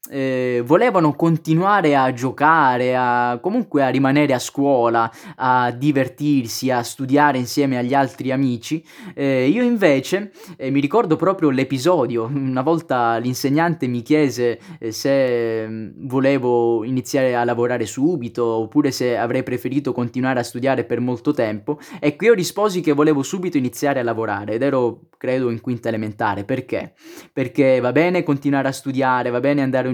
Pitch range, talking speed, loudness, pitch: 120-150 Hz, 150 wpm, -19 LUFS, 130 Hz